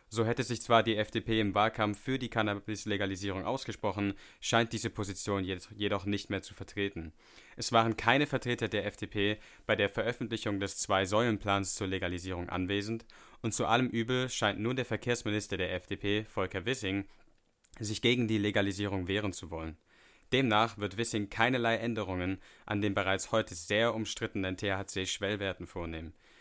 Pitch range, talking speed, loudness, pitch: 95-115 Hz, 150 wpm, -32 LUFS, 105 Hz